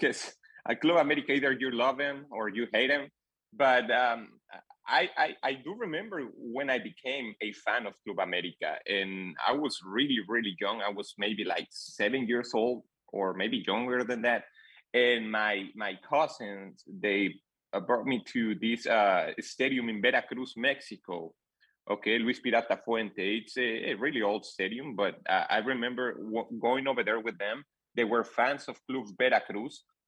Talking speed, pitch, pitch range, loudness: 170 wpm, 120 Hz, 105-130 Hz, -30 LUFS